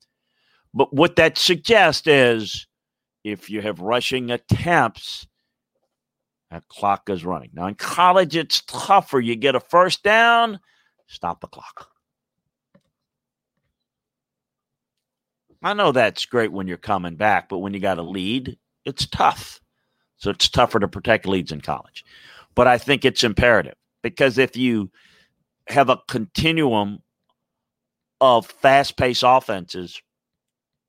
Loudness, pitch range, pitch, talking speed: -19 LUFS, 100-140 Hz, 120 Hz, 130 wpm